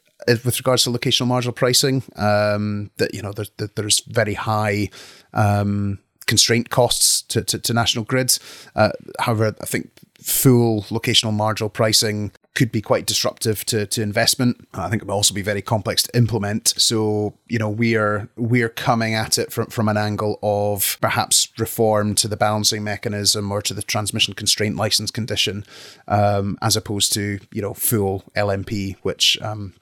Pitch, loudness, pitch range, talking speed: 105 Hz, -19 LUFS, 105-115 Hz, 170 wpm